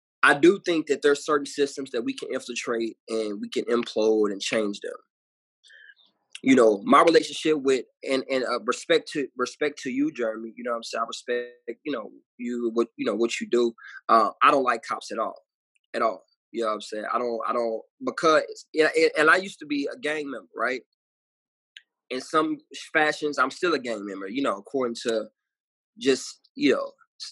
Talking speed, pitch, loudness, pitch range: 200 wpm, 125 Hz, -25 LUFS, 115-155 Hz